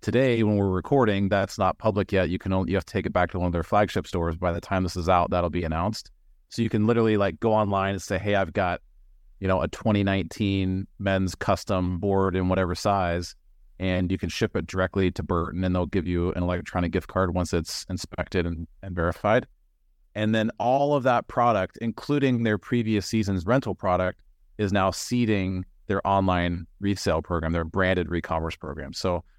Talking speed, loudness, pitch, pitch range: 205 wpm, -25 LUFS, 95 Hz, 90-105 Hz